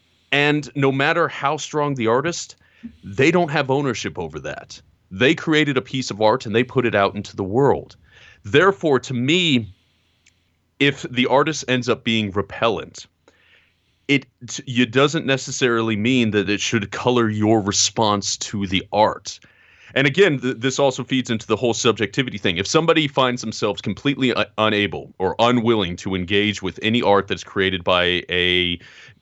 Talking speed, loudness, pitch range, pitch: 160 wpm, -19 LUFS, 105-135 Hz, 120 Hz